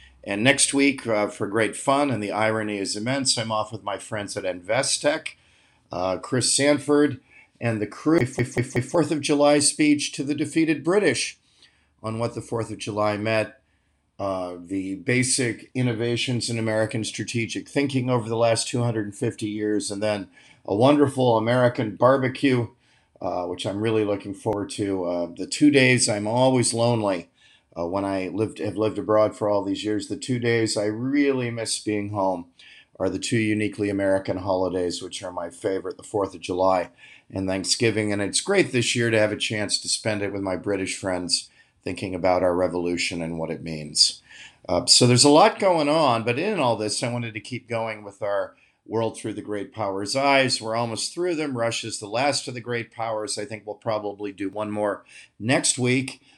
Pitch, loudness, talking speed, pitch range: 110 Hz, -23 LUFS, 190 wpm, 100-125 Hz